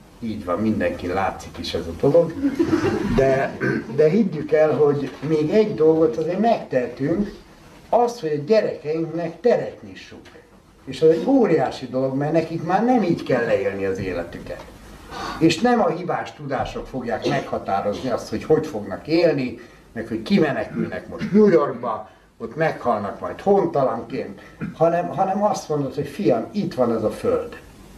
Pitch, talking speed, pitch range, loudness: 160 Hz, 150 wpm, 135-200 Hz, -21 LUFS